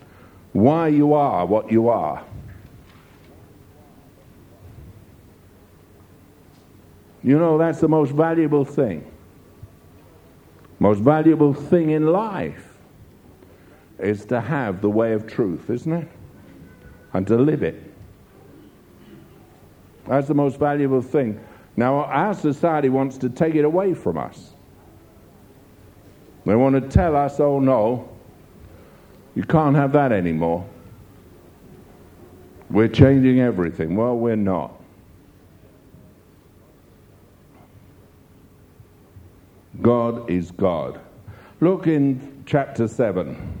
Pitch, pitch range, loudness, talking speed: 115 Hz, 95-145 Hz, -20 LUFS, 100 wpm